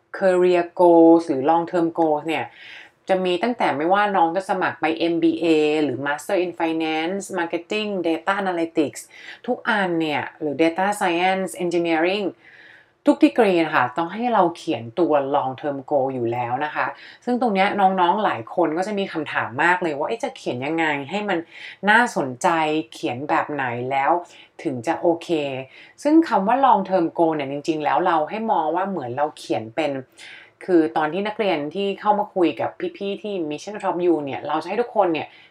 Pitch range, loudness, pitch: 155-190 Hz, -21 LUFS, 170 Hz